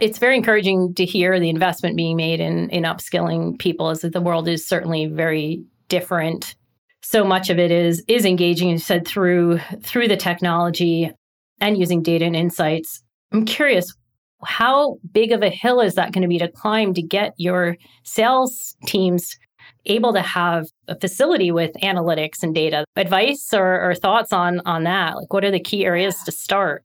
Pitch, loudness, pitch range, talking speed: 180 Hz, -19 LUFS, 170-200 Hz, 185 wpm